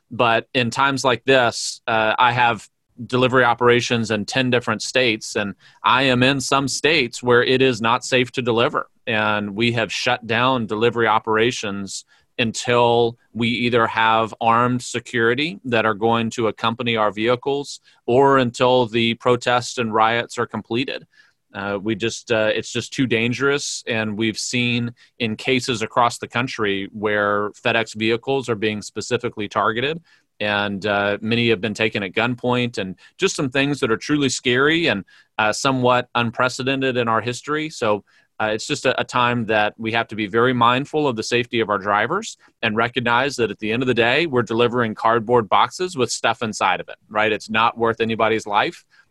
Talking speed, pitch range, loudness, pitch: 175 wpm, 110-125 Hz, -19 LUFS, 120 Hz